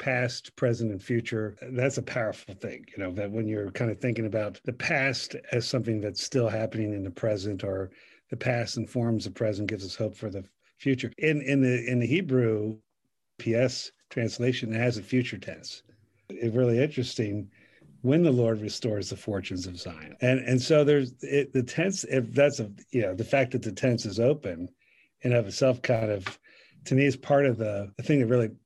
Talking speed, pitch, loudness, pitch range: 205 wpm, 120 Hz, -28 LUFS, 105-130 Hz